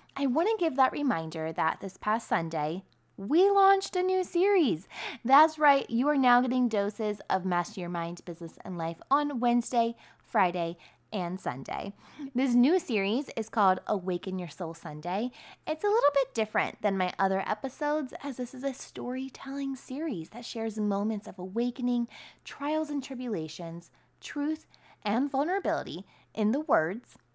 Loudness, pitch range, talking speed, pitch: -29 LUFS, 190-280 Hz, 160 wpm, 240 Hz